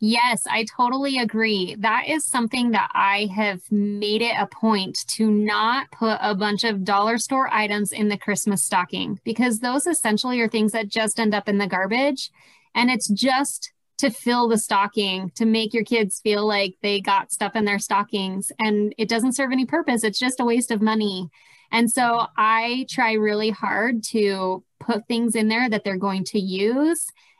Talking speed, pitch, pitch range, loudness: 190 wpm, 220 Hz, 205-240 Hz, -21 LUFS